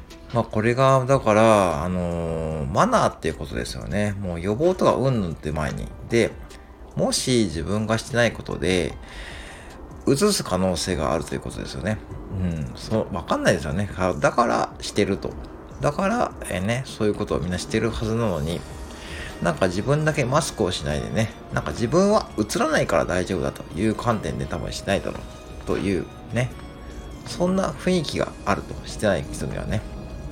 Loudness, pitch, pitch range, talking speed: -23 LUFS, 90 Hz, 75-115 Hz, 355 characters per minute